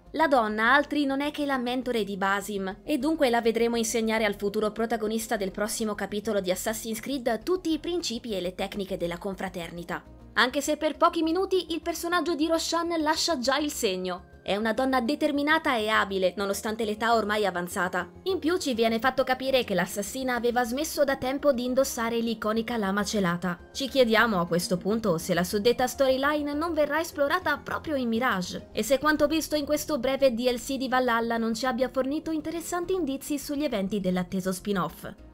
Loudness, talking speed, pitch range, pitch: -27 LUFS, 180 wpm, 205-290 Hz, 245 Hz